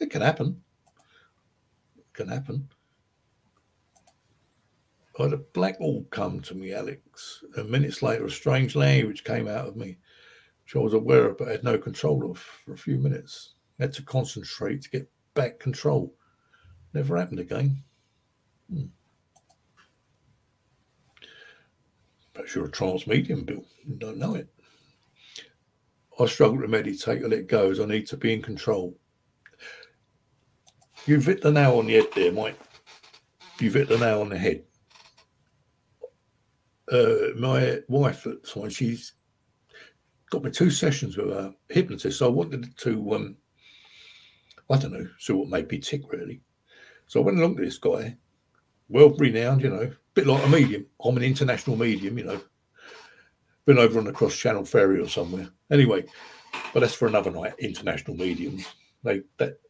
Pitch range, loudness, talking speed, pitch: 110-150 Hz, -25 LUFS, 160 wpm, 135 Hz